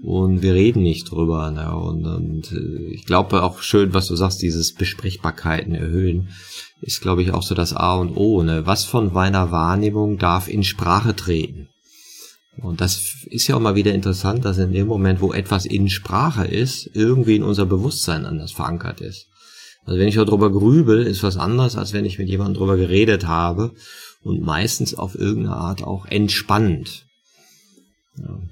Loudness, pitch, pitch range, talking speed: -19 LUFS, 95 Hz, 90-105 Hz, 180 wpm